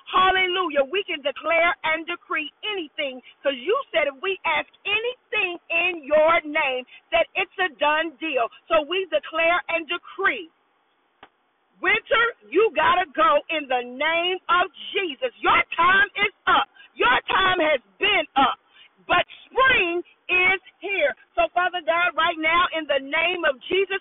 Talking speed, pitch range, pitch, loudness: 150 wpm, 315-385 Hz, 345 Hz, -22 LUFS